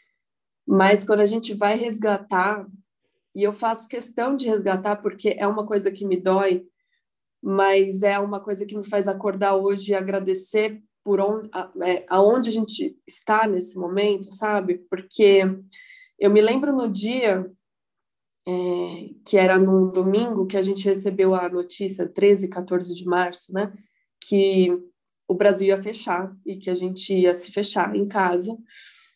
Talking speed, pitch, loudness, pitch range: 155 wpm, 200 Hz, -22 LUFS, 185-210 Hz